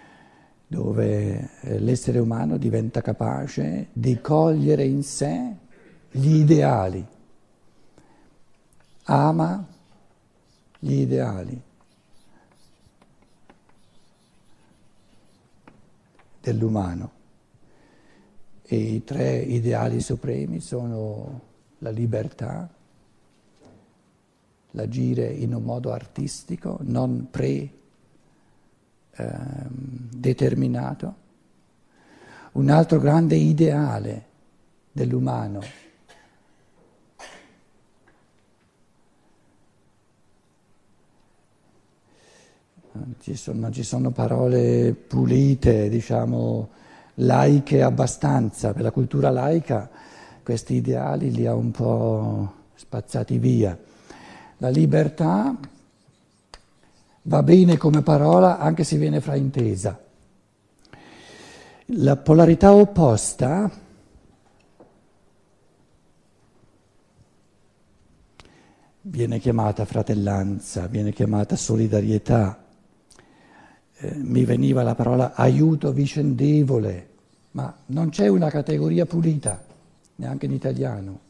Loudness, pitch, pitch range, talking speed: -21 LUFS, 120 Hz, 105-150 Hz, 70 wpm